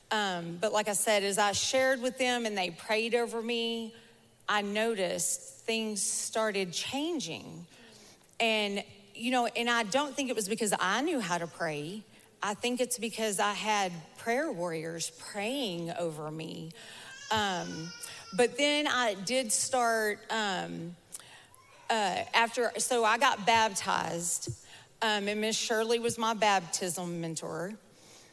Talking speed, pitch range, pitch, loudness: 140 wpm, 180-235 Hz, 215 Hz, -30 LUFS